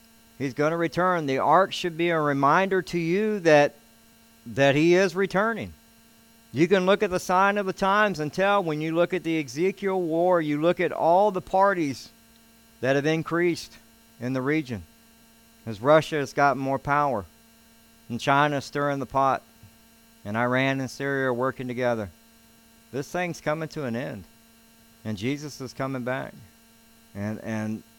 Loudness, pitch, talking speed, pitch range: -24 LUFS, 135 Hz, 170 wpm, 115-165 Hz